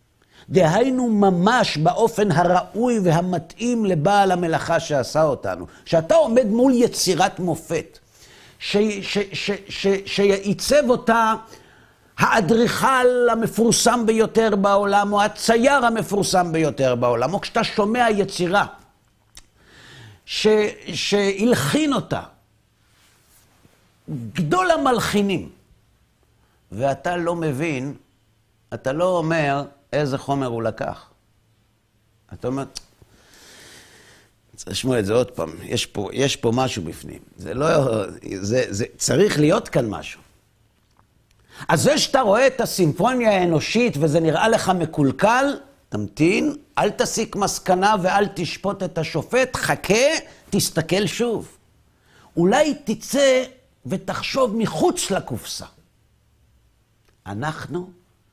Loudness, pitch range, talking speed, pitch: -20 LUFS, 135-220 Hz, 100 wpm, 185 Hz